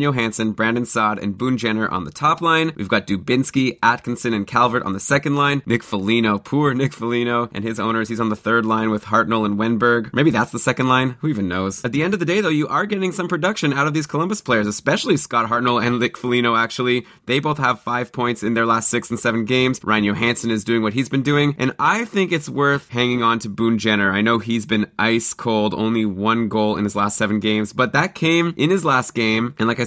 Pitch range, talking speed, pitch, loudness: 110-130 Hz, 245 wpm, 120 Hz, -19 LUFS